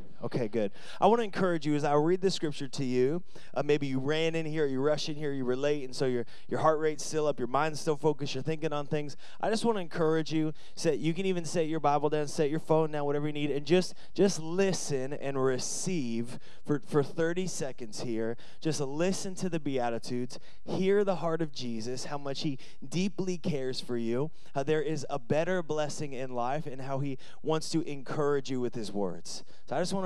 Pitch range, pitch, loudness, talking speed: 135-165 Hz, 150 Hz, -31 LUFS, 225 wpm